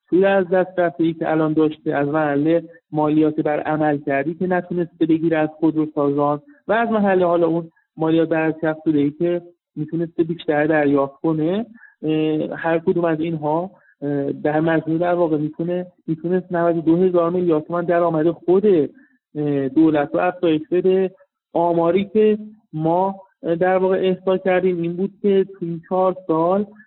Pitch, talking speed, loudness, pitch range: 170 Hz, 145 wpm, -20 LUFS, 155-185 Hz